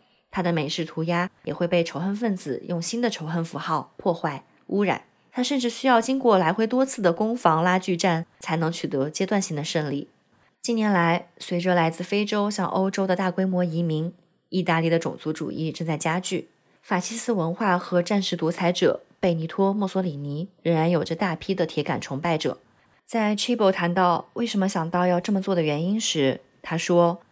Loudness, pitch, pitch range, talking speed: -24 LUFS, 175 Hz, 165-195 Hz, 295 characters per minute